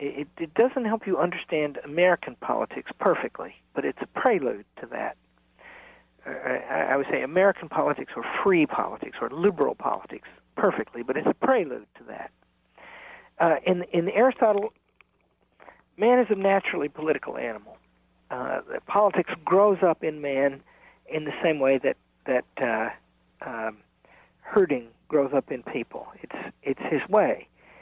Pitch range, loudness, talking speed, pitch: 135-200 Hz, -26 LUFS, 145 wpm, 165 Hz